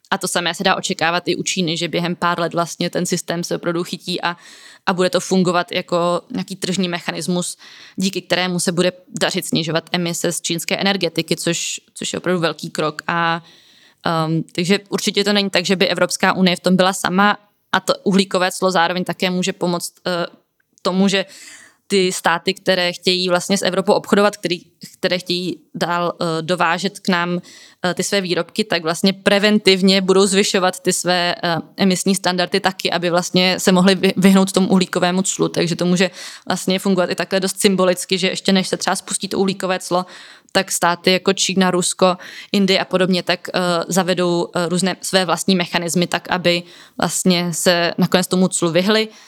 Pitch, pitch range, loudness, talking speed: 180 Hz, 175-190 Hz, -18 LUFS, 180 wpm